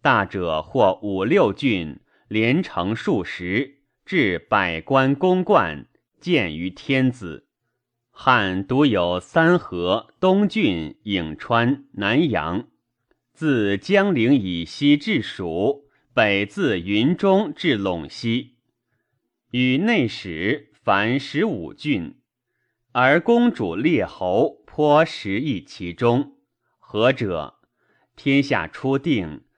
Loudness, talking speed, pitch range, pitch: -21 LUFS, 135 characters per minute, 100-145 Hz, 125 Hz